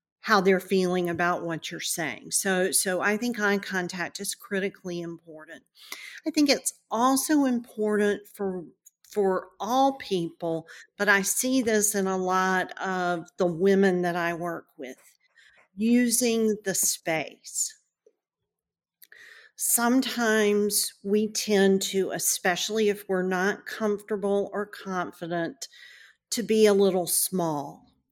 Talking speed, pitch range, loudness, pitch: 125 wpm, 185-215 Hz, -25 LUFS, 200 Hz